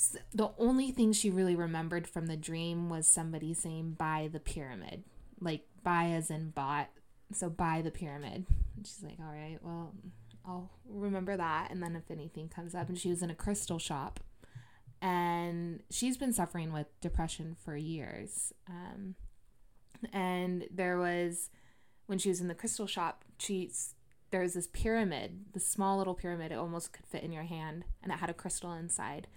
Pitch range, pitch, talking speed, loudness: 160-185 Hz, 170 Hz, 180 wpm, -36 LUFS